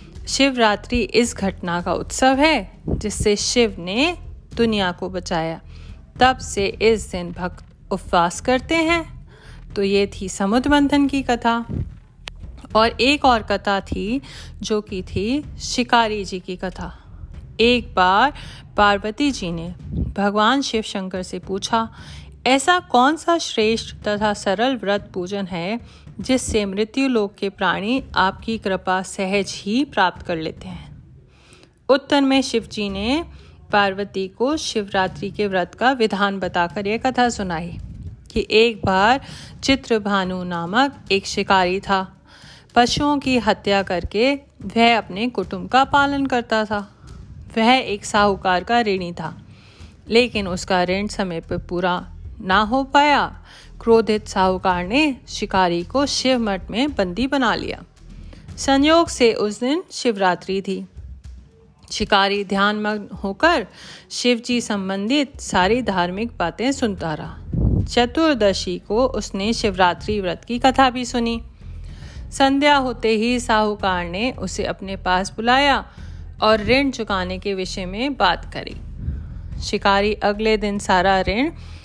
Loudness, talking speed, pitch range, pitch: -20 LUFS, 130 wpm, 190-245 Hz, 210 Hz